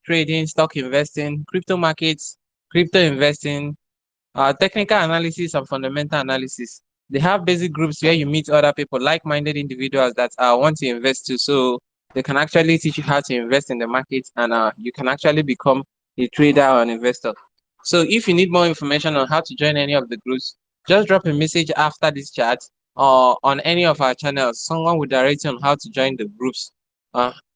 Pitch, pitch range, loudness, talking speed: 145 Hz, 130-160 Hz, -18 LUFS, 200 wpm